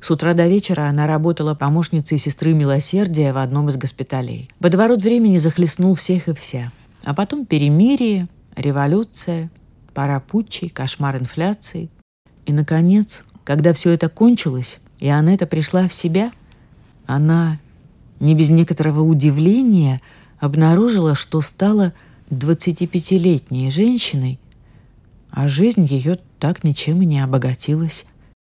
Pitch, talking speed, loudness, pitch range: 160 Hz, 120 wpm, -17 LUFS, 140-180 Hz